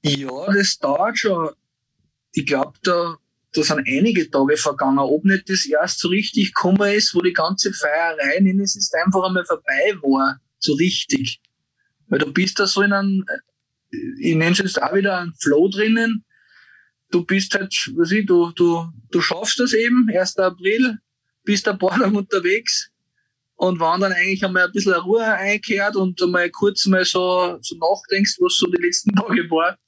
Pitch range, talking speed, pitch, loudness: 175-210 Hz, 175 wpm, 195 Hz, -18 LUFS